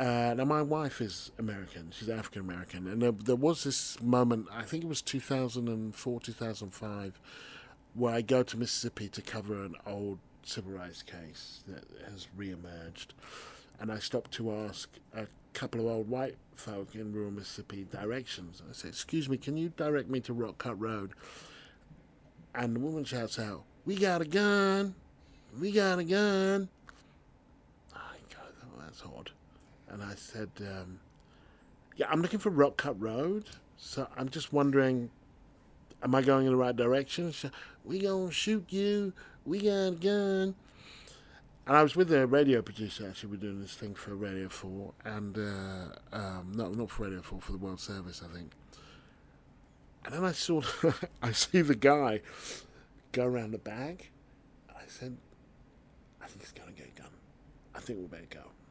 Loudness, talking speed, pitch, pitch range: -33 LUFS, 175 wpm, 120 Hz, 100-145 Hz